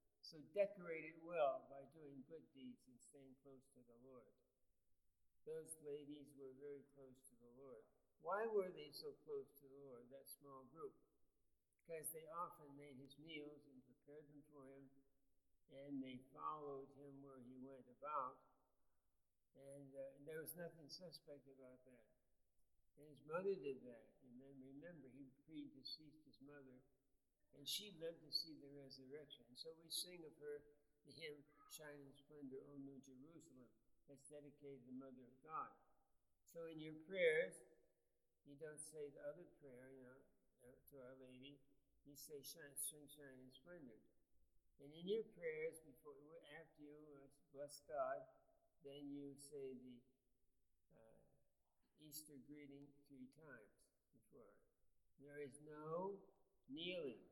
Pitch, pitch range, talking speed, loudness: 145 Hz, 135-155 Hz, 155 wpm, -53 LUFS